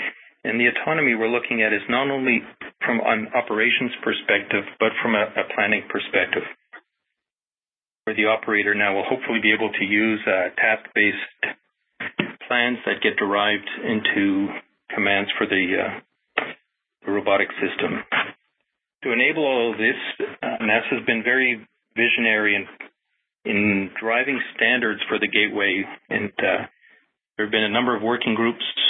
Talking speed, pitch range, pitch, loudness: 145 wpm, 105-120 Hz, 110 Hz, -21 LUFS